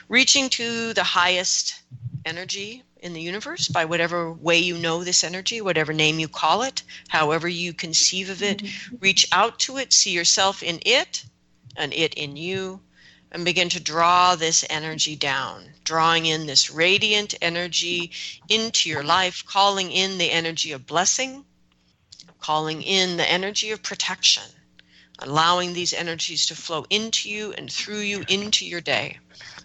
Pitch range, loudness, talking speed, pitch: 160-195 Hz, -21 LUFS, 155 wpm, 175 Hz